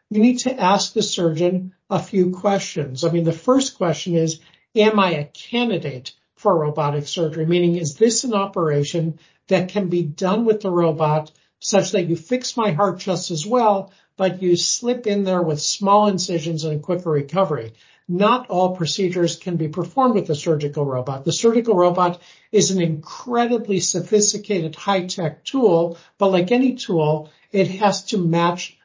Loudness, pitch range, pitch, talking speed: -20 LUFS, 165-205 Hz, 180 Hz, 170 wpm